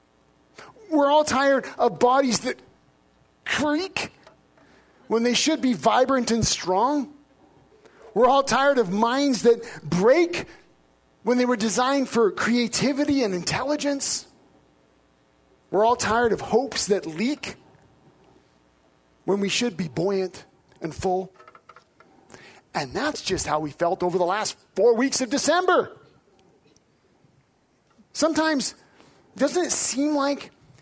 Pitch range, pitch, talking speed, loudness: 185-280 Hz, 240 Hz, 120 wpm, -23 LUFS